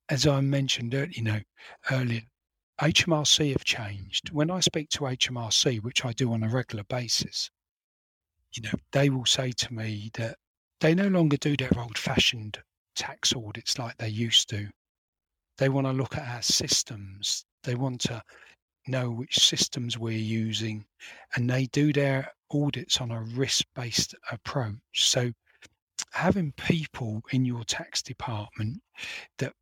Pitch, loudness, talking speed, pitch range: 125 Hz, -27 LUFS, 150 wpm, 110-140 Hz